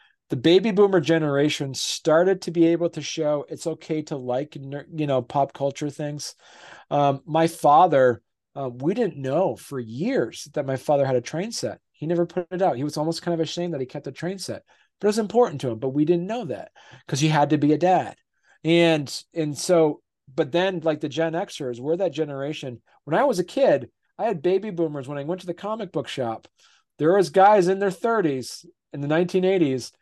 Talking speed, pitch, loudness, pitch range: 220 wpm, 155 Hz, -23 LUFS, 140-175 Hz